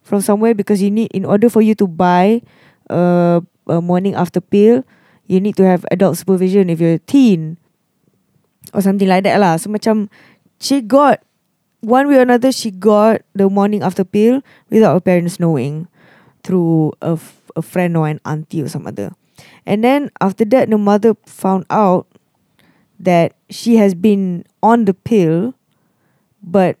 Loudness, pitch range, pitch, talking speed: -14 LUFS, 175-215 Hz, 195 Hz, 170 wpm